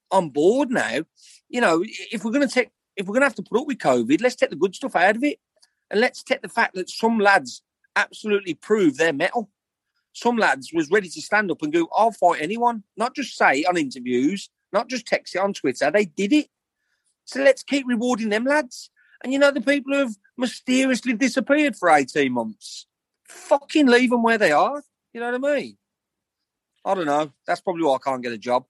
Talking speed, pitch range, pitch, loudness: 225 wpm, 200-275 Hz, 240 Hz, -21 LUFS